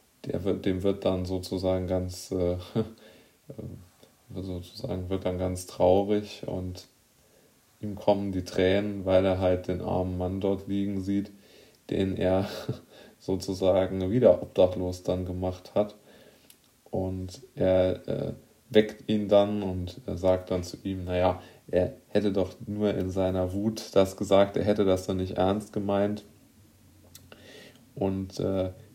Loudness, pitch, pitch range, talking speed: -28 LUFS, 95 Hz, 90-105 Hz, 135 wpm